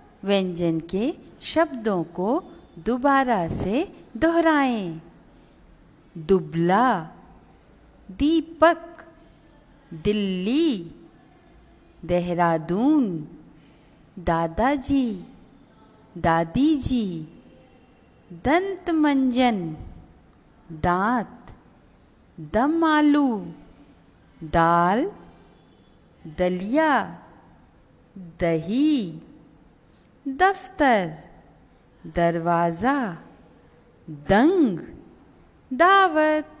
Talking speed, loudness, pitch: 40 wpm, -22 LUFS, 200 Hz